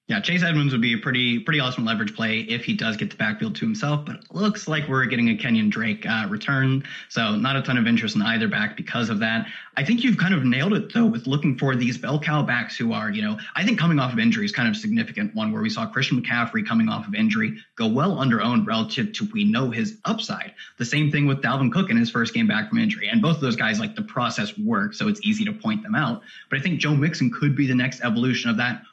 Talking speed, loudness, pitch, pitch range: 275 wpm, -22 LUFS, 205 Hz, 135-220 Hz